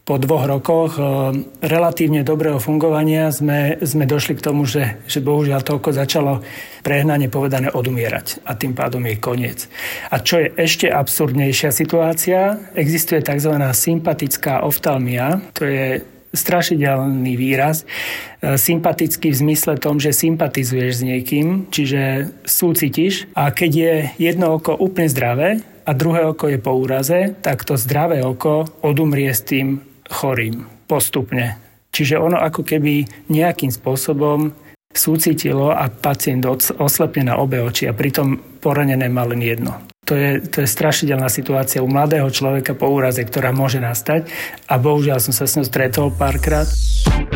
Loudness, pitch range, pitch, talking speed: -17 LUFS, 135-160 Hz, 145 Hz, 140 wpm